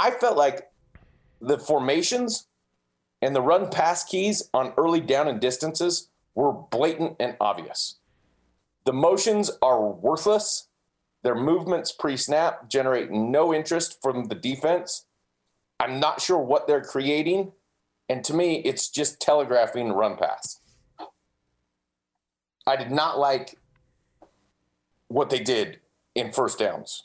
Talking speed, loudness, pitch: 125 wpm, -24 LUFS, 135 Hz